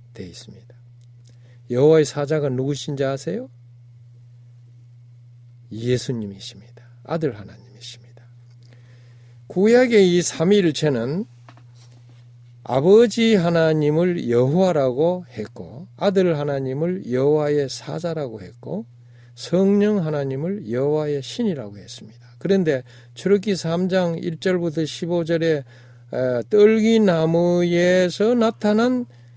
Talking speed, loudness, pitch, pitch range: 225 characters per minute, -20 LUFS, 140 Hz, 120-175 Hz